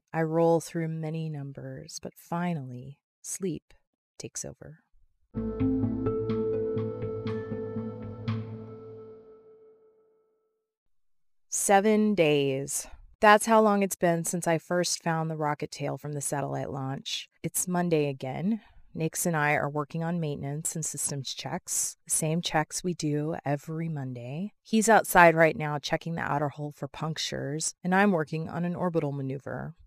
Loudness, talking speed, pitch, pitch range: -28 LUFS, 130 wpm, 155 Hz, 135-175 Hz